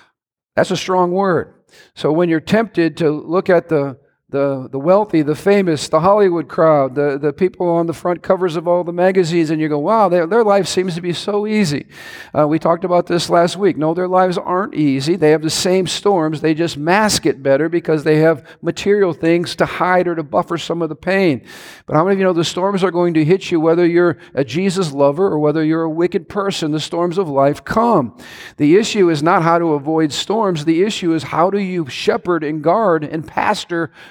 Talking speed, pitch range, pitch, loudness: 225 wpm, 155-185 Hz, 170 Hz, -16 LUFS